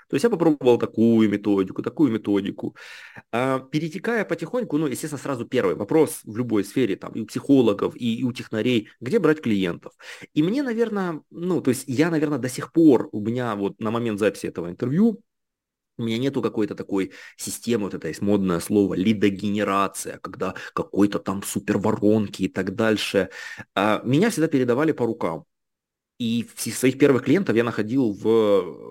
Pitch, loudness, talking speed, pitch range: 115 Hz, -23 LUFS, 160 wpm, 105-145 Hz